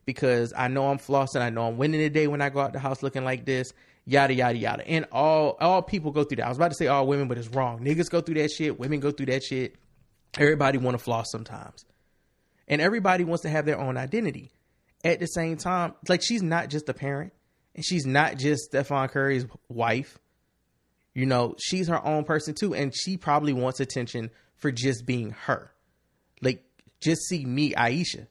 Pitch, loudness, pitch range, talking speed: 140 Hz, -26 LUFS, 130-155 Hz, 215 wpm